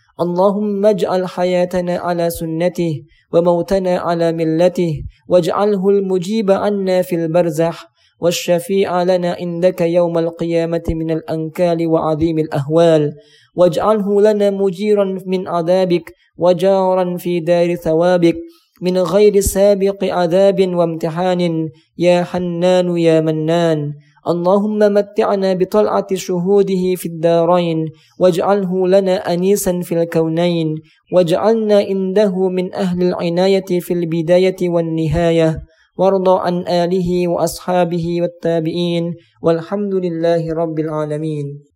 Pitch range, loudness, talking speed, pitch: 165-190 Hz, -16 LUFS, 100 wpm, 175 Hz